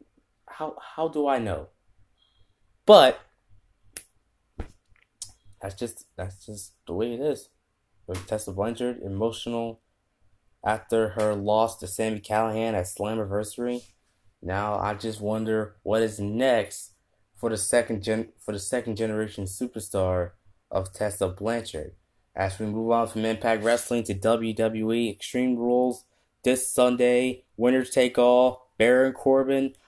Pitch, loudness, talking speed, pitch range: 110 Hz, -25 LUFS, 125 wpm, 100-120 Hz